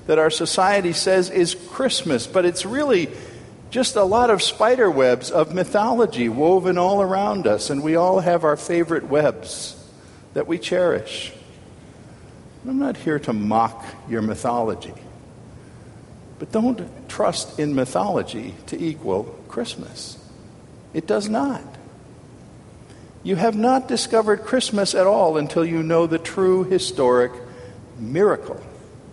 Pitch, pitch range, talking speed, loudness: 180 Hz, 150-205 Hz, 130 wpm, -20 LUFS